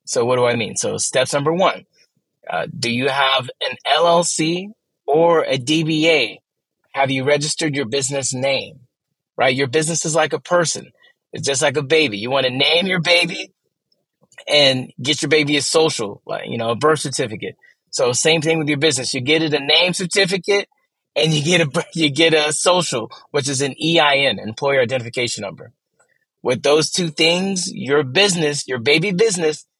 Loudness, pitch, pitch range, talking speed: -17 LUFS, 155 Hz, 135-165 Hz, 180 wpm